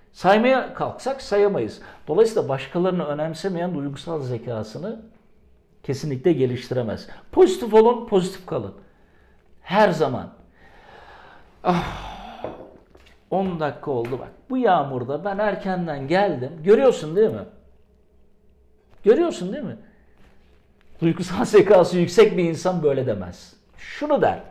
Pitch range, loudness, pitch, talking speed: 150-230 Hz, -21 LUFS, 185 Hz, 100 wpm